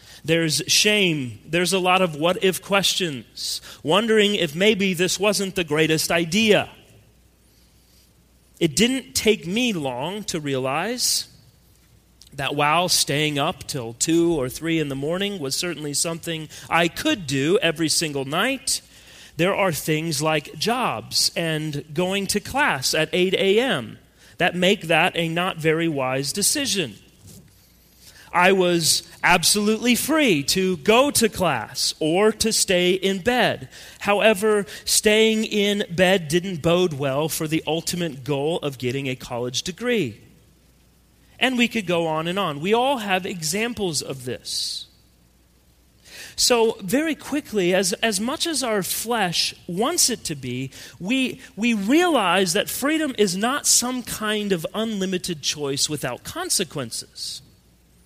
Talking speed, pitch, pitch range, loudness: 135 wpm, 180 Hz, 150-210 Hz, -21 LUFS